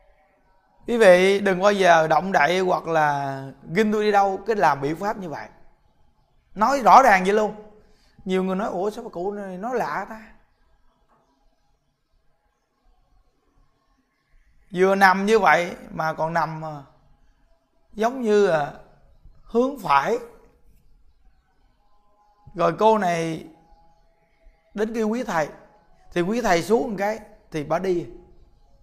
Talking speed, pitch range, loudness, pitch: 130 wpm, 165-215 Hz, -21 LUFS, 195 Hz